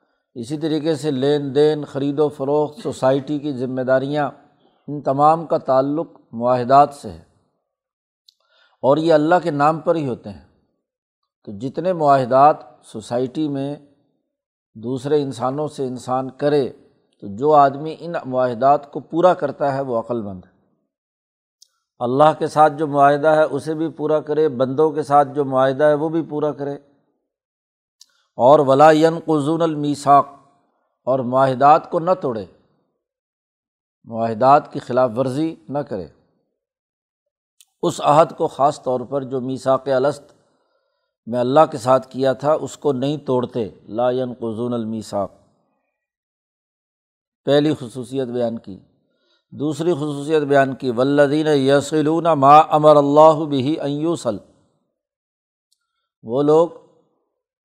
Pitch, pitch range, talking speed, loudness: 145 Hz, 130-155 Hz, 130 wpm, -18 LUFS